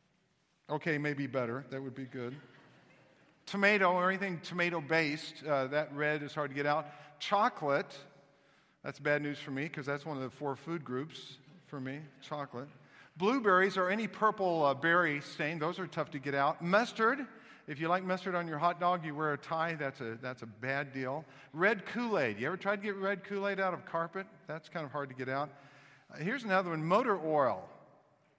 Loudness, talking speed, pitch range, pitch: -34 LUFS, 205 wpm, 140-180 Hz, 150 Hz